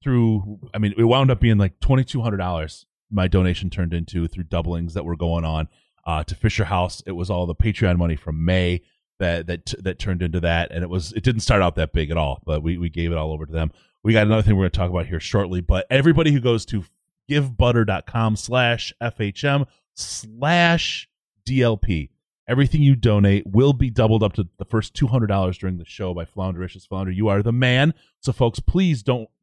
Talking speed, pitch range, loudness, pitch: 210 wpm, 90-120 Hz, -21 LUFS, 100 Hz